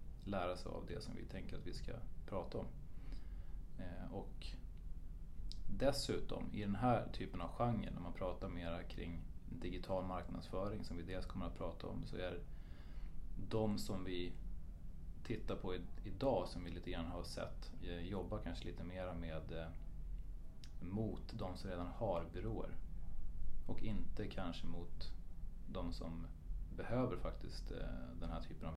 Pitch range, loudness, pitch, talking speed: 80-95 Hz, -46 LUFS, 85 Hz, 150 wpm